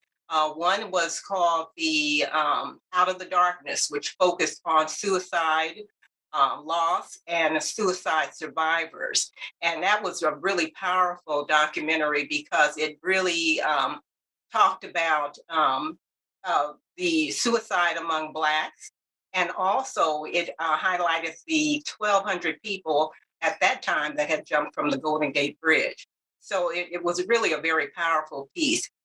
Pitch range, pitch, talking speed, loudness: 155-190 Hz, 170 Hz, 135 wpm, -25 LUFS